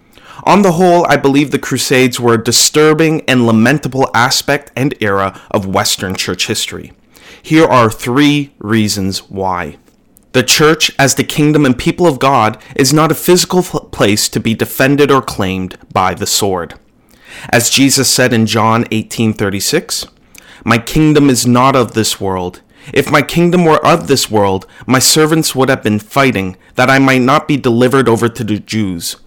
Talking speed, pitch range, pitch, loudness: 170 wpm, 110-145 Hz, 130 Hz, -11 LUFS